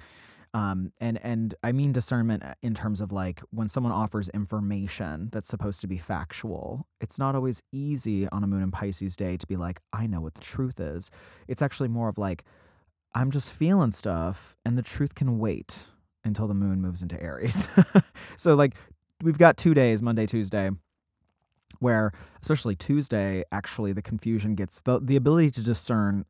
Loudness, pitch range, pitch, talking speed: -27 LUFS, 95-120 Hz, 105 Hz, 180 wpm